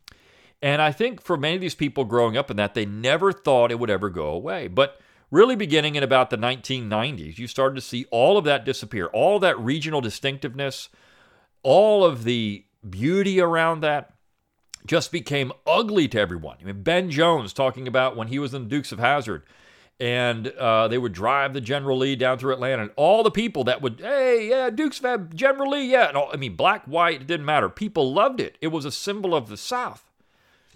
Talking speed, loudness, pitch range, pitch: 210 wpm, -22 LUFS, 120-170 Hz, 140 Hz